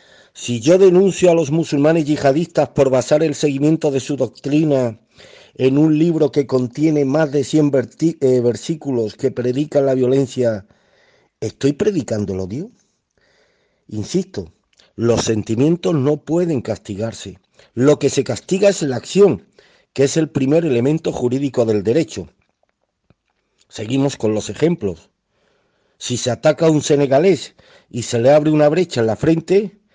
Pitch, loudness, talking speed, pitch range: 140 Hz, -17 LUFS, 140 wpm, 120-160 Hz